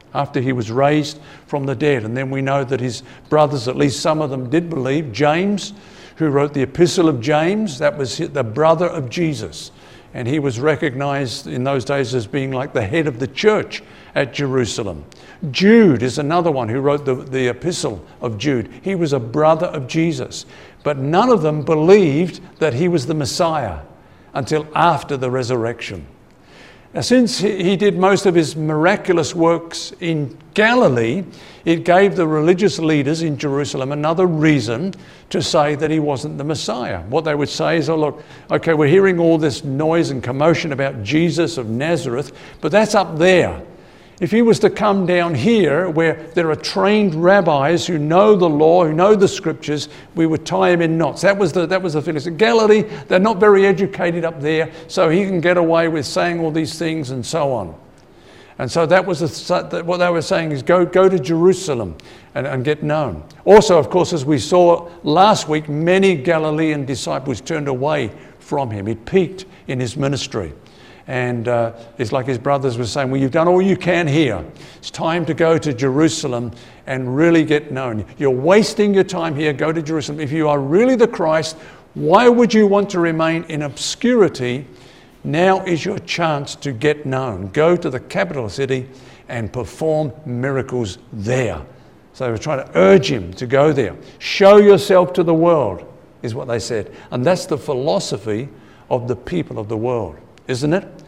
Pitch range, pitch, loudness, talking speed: 135-175 Hz, 155 Hz, -17 LUFS, 190 wpm